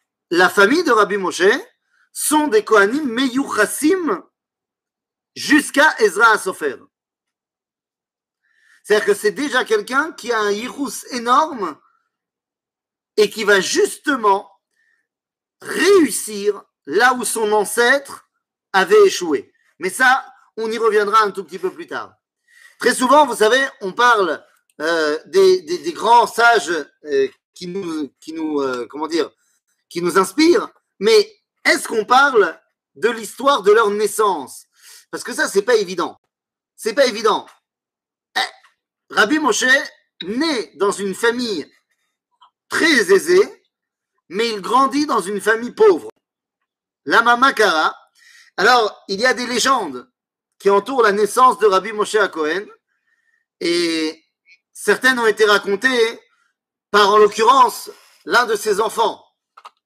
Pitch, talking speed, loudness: 255 Hz, 130 wpm, -16 LUFS